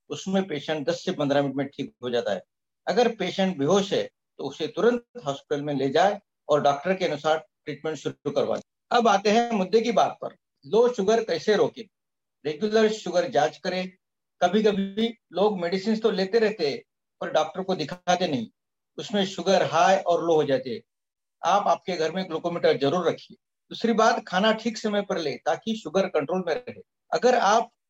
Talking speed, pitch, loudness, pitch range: 180 wpm, 185 Hz, -25 LUFS, 160-220 Hz